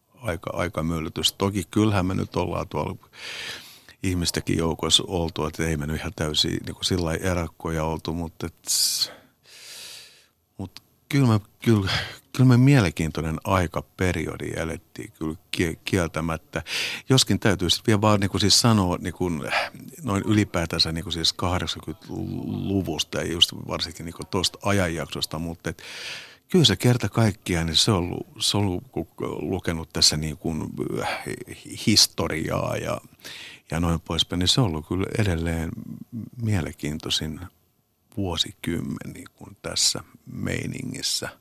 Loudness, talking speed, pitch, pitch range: -24 LUFS, 130 wpm, 90 Hz, 80-105 Hz